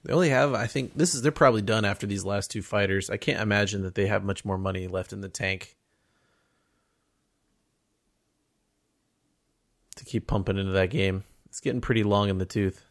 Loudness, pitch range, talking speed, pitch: -26 LUFS, 95-115 Hz, 190 wpm, 100 Hz